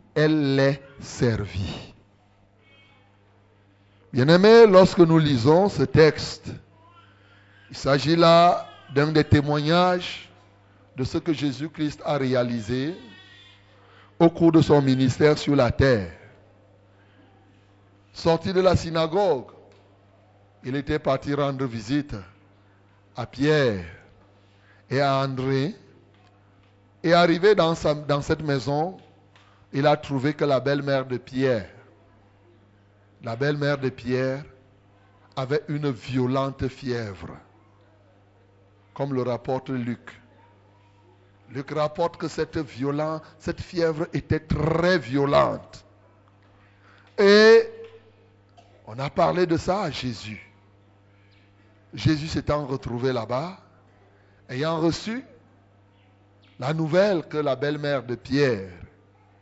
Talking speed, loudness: 100 wpm, -22 LUFS